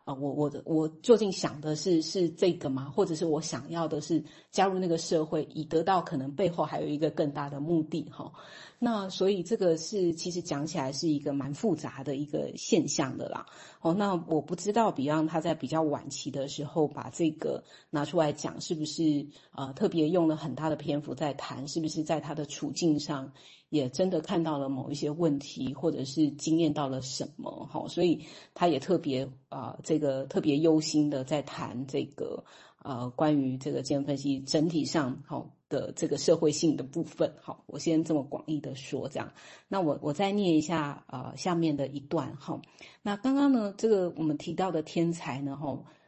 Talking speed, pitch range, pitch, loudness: 290 characters per minute, 145-165 Hz, 155 Hz, -30 LUFS